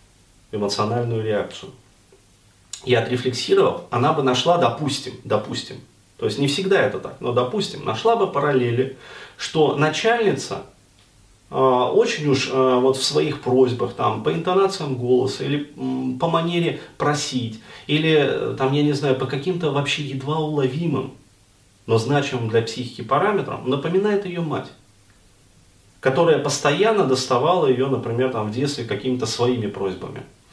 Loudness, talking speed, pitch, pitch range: -21 LUFS, 135 wpm, 130 Hz, 115-145 Hz